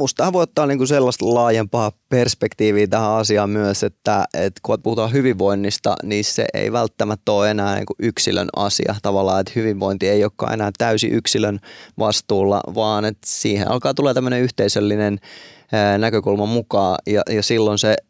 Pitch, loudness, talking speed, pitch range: 105 Hz, -18 LUFS, 155 wpm, 100-120 Hz